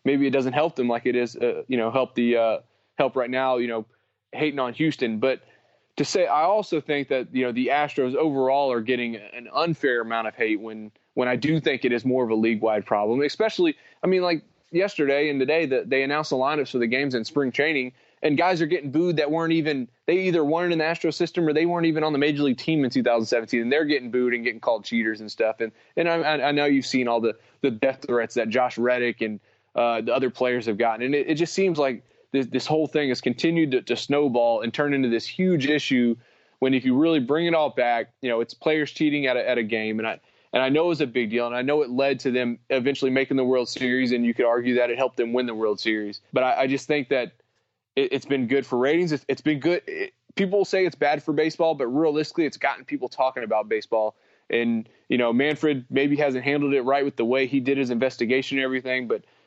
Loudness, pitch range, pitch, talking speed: -24 LUFS, 120-155 Hz, 135 Hz, 255 wpm